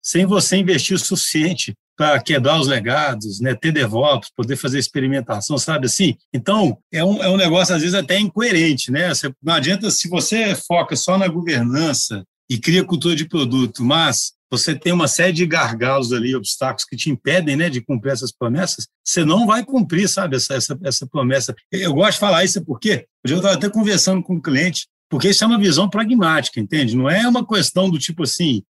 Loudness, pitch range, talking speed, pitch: -17 LUFS, 135-185 Hz, 200 wpm, 160 Hz